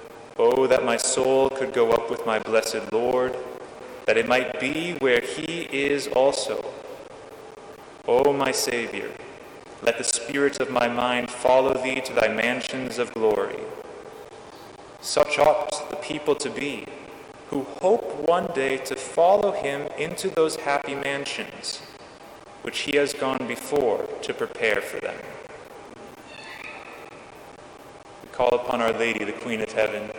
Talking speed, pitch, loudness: 140 wpm, 150 Hz, -24 LUFS